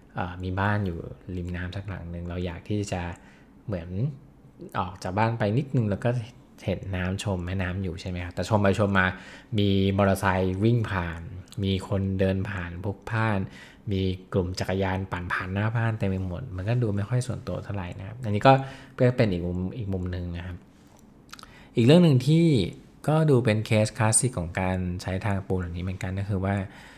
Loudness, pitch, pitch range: -26 LUFS, 95 Hz, 90-110 Hz